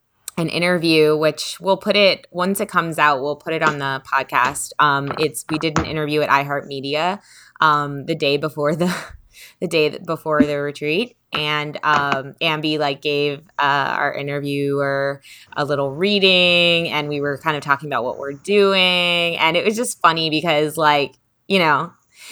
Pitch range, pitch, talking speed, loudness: 145-170 Hz, 155 Hz, 170 wpm, -18 LUFS